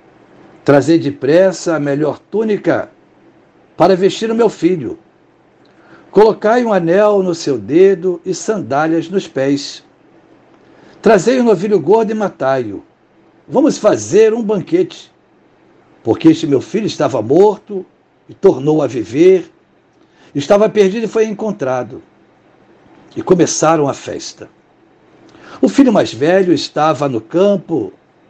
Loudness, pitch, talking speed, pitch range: -13 LUFS, 195 Hz, 120 wpm, 165-220 Hz